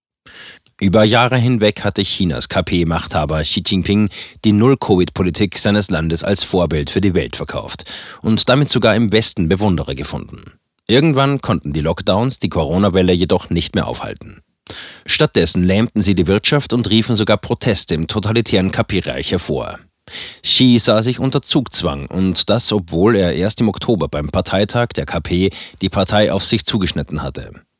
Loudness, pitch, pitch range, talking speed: -15 LUFS, 100 Hz, 85-110 Hz, 150 wpm